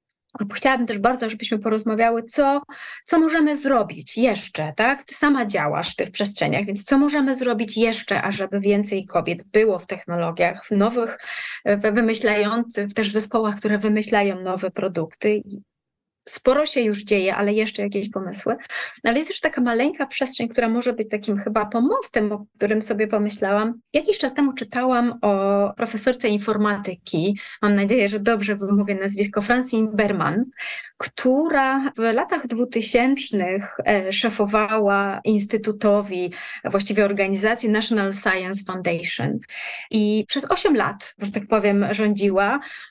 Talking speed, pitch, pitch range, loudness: 135 wpm, 215 Hz, 200-240 Hz, -21 LUFS